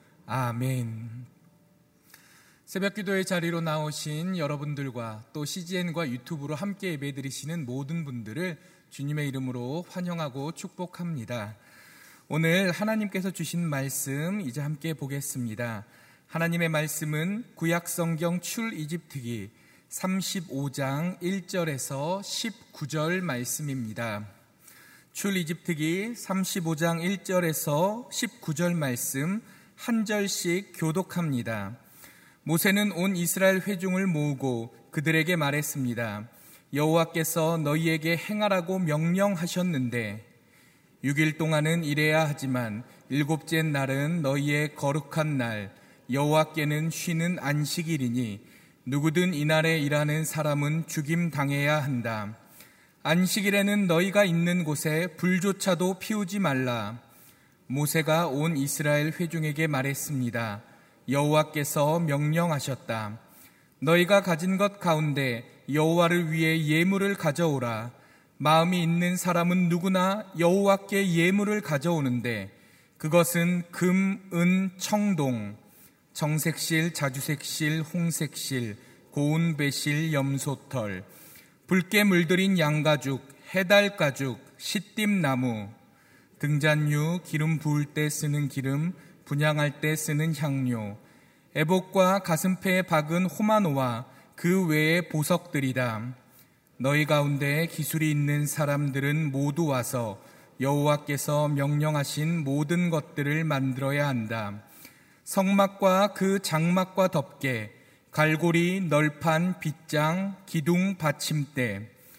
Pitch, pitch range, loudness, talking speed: 155 Hz, 140-175 Hz, -27 LUFS, 240 characters per minute